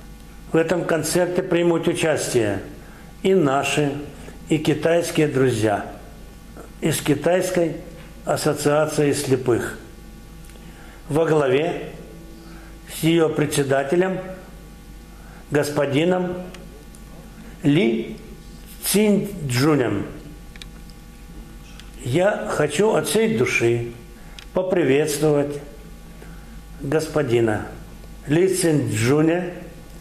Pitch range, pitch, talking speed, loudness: 145-175 Hz, 155 Hz, 60 wpm, -21 LUFS